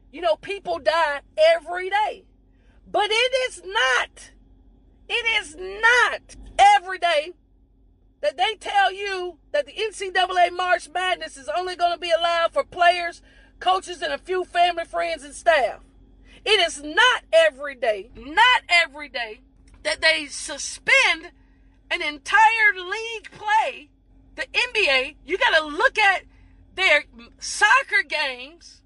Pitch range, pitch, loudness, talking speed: 315-400 Hz, 350 Hz, -21 LUFS, 135 wpm